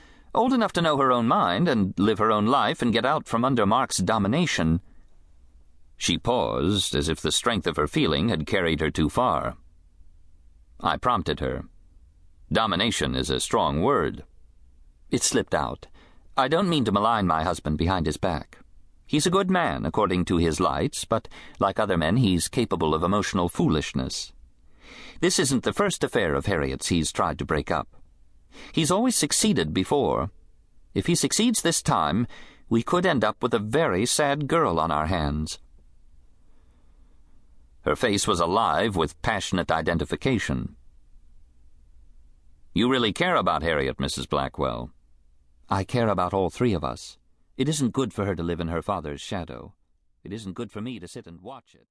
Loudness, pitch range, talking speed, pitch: -24 LUFS, 70-100 Hz, 170 wpm, 80 Hz